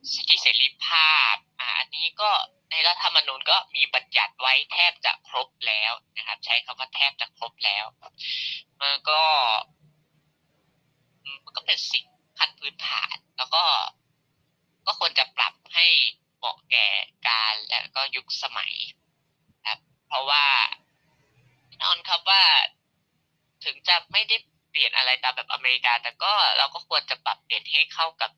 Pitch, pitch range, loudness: 150 Hz, 130-165 Hz, -22 LUFS